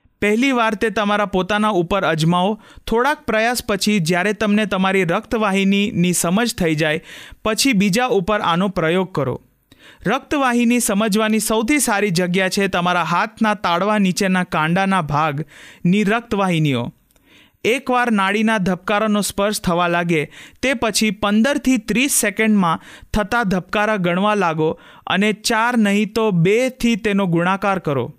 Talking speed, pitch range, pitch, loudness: 125 wpm, 180-220 Hz, 205 Hz, -18 LUFS